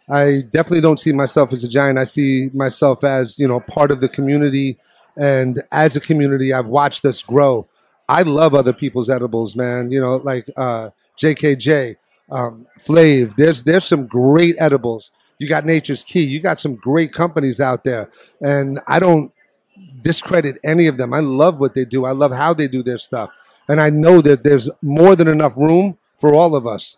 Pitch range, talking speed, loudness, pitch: 130-155 Hz, 195 wpm, -15 LUFS, 140 Hz